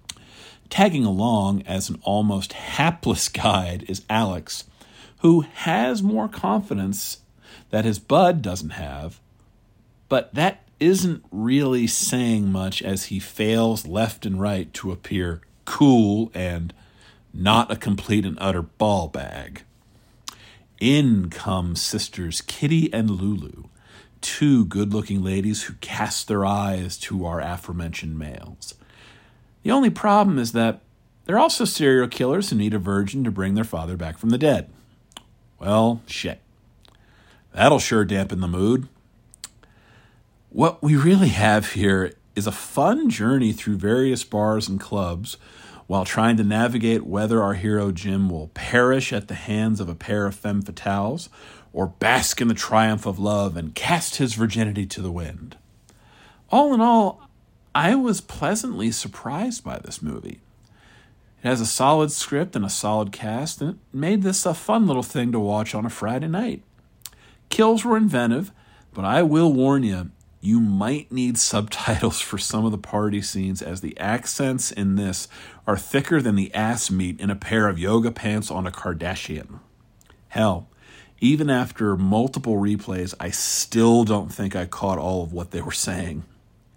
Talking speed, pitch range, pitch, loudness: 155 wpm, 95-120 Hz, 110 Hz, -22 LUFS